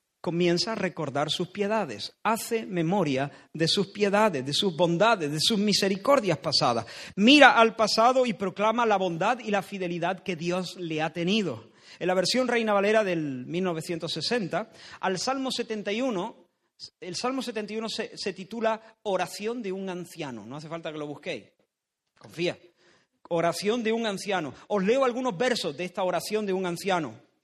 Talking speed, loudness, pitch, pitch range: 160 wpm, -26 LUFS, 190 Hz, 170-220 Hz